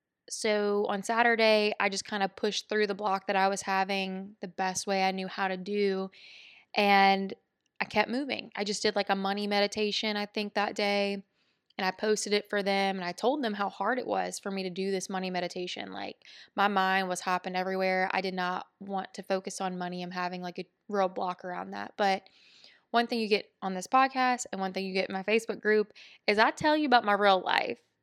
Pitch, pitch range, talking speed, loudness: 195 Hz, 190-210 Hz, 225 wpm, -29 LUFS